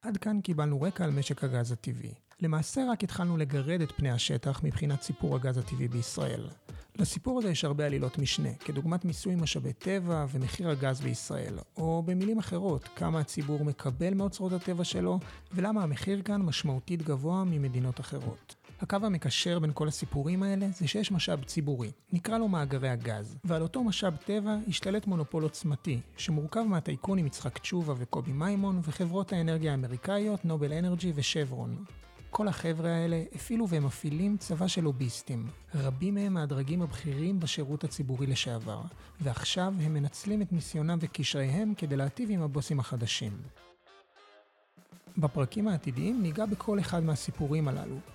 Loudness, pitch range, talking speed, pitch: -32 LUFS, 140-185 Hz, 145 wpm, 155 Hz